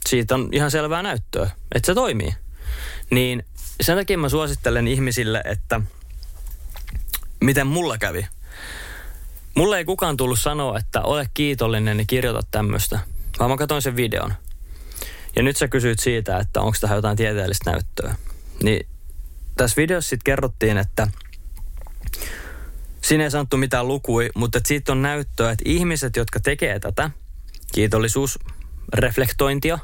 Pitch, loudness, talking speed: 110 Hz, -21 LUFS, 135 wpm